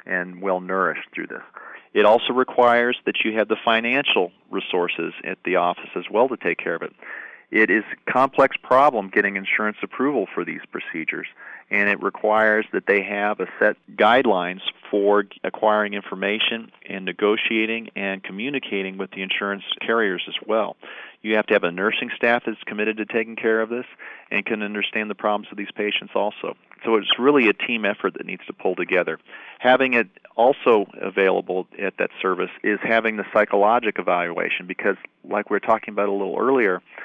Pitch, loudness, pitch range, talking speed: 105 Hz, -21 LUFS, 100-115 Hz, 180 wpm